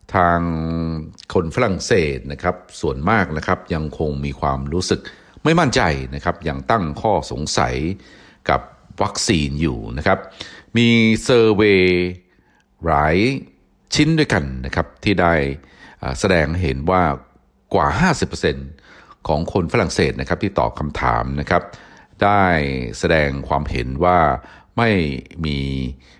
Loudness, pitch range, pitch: -19 LUFS, 70-90 Hz, 80 Hz